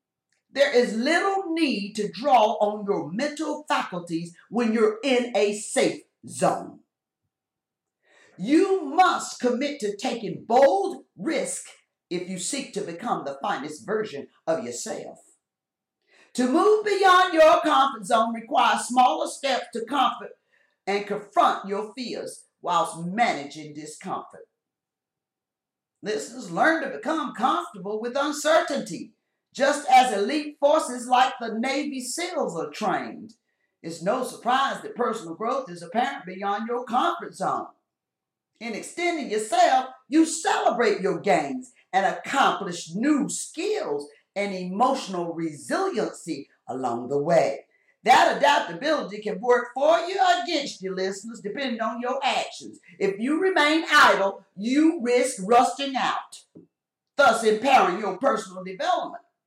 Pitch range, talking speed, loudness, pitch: 205-305 Hz, 125 wpm, -24 LUFS, 250 Hz